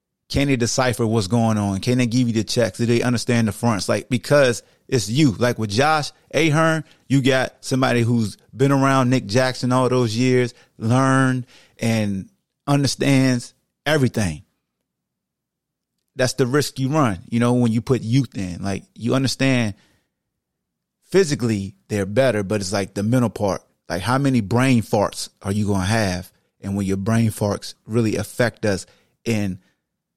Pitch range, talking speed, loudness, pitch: 105-130 Hz, 165 wpm, -20 LUFS, 120 Hz